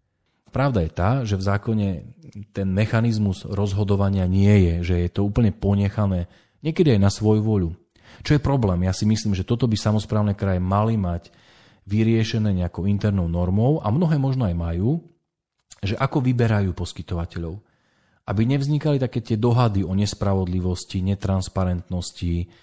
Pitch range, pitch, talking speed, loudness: 95-115 Hz, 100 Hz, 145 wpm, -22 LUFS